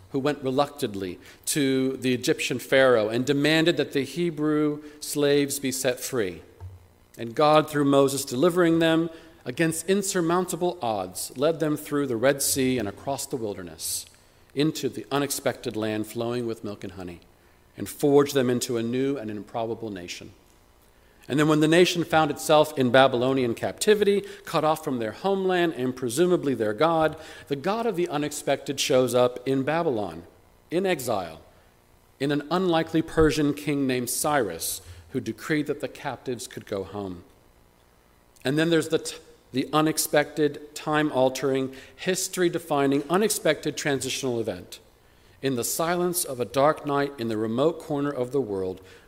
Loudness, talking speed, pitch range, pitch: -25 LUFS, 155 wpm, 115-155 Hz, 140 Hz